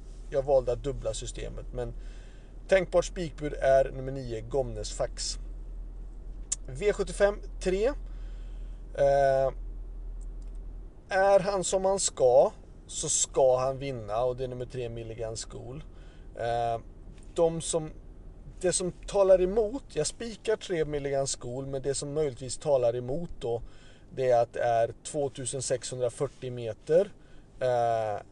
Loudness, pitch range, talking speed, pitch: -29 LUFS, 115-155 Hz, 125 wpm, 130 Hz